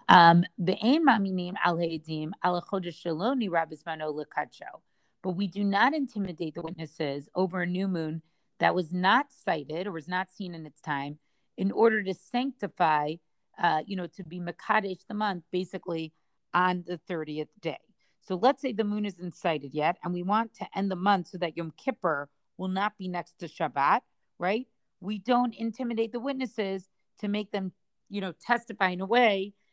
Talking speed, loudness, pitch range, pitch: 160 wpm, -29 LUFS, 165-210 Hz, 185 Hz